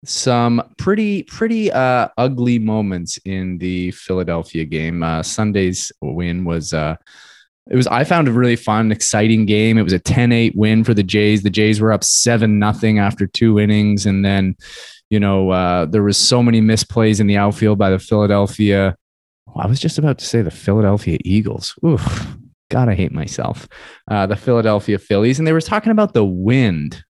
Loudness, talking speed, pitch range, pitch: -16 LUFS, 185 wpm, 95-120 Hz, 105 Hz